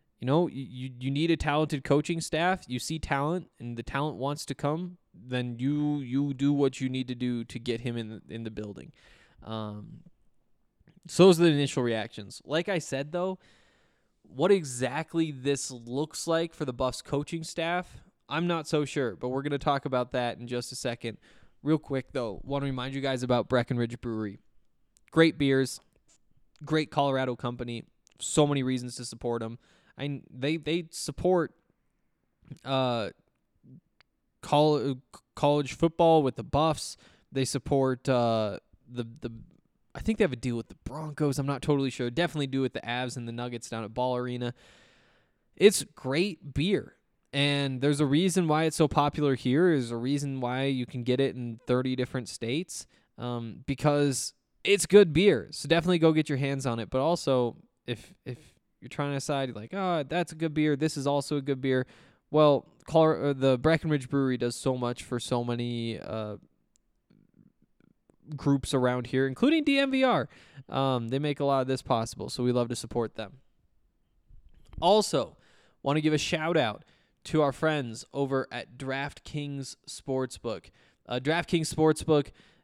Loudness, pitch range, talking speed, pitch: -28 LUFS, 125-155 Hz, 175 wpm, 140 Hz